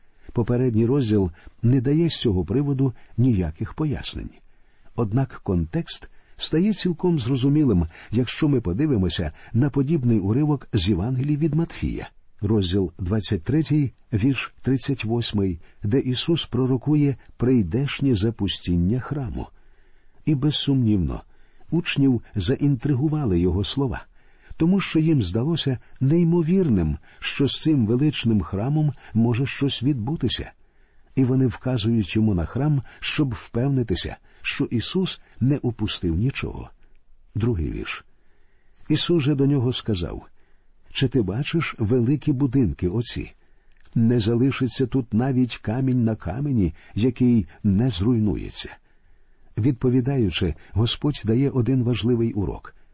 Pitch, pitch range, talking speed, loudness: 125 Hz, 105-140 Hz, 110 wpm, -23 LUFS